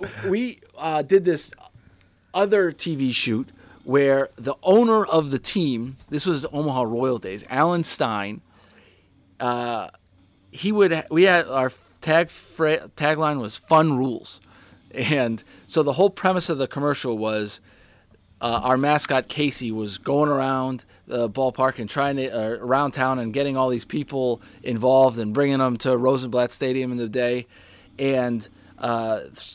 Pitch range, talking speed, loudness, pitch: 115-150 Hz, 150 wpm, -22 LUFS, 130 Hz